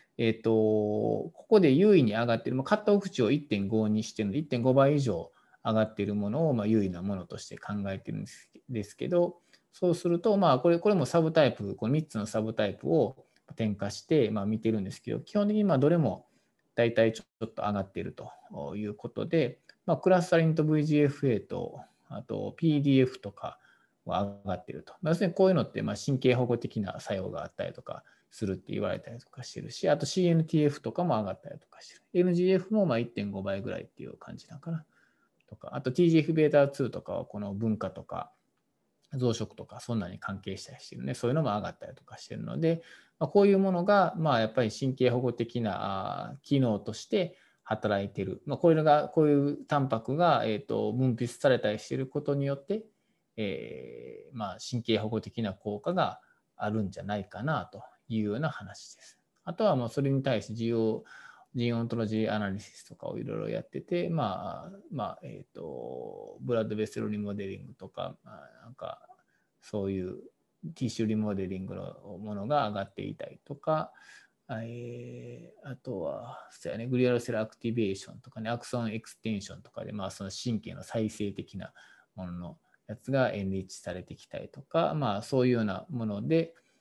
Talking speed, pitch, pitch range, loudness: 385 characters per minute, 120 Hz, 105-160 Hz, -30 LUFS